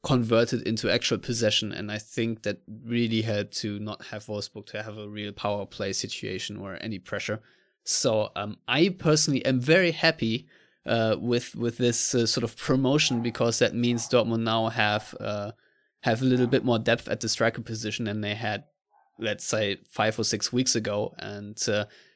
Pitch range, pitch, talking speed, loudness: 105-120 Hz, 115 Hz, 185 wpm, -26 LUFS